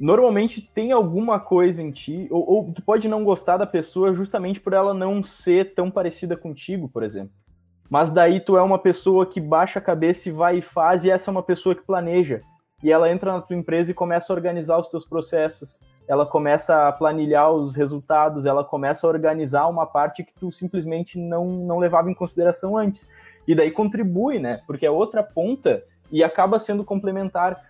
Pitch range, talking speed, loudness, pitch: 160-190 Hz, 195 wpm, -21 LUFS, 175 Hz